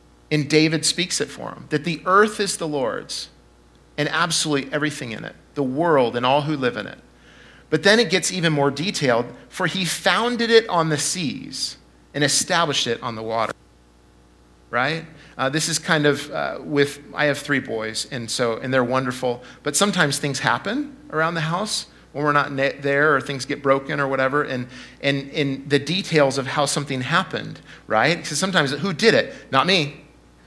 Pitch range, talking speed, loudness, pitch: 125-165 Hz, 190 wpm, -21 LUFS, 145 Hz